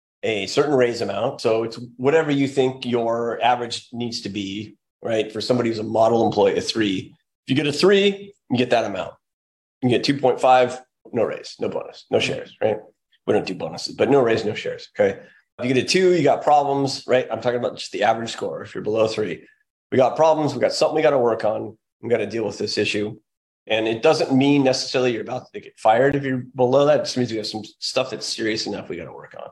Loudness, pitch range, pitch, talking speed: -21 LUFS, 115-145 Hz, 125 Hz, 245 wpm